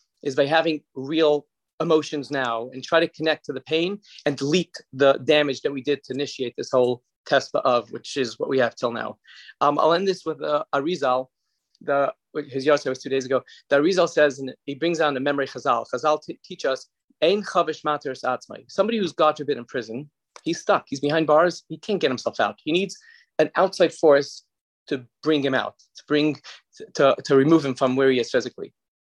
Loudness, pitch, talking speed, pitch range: -23 LUFS, 150 Hz, 210 wpm, 135-160 Hz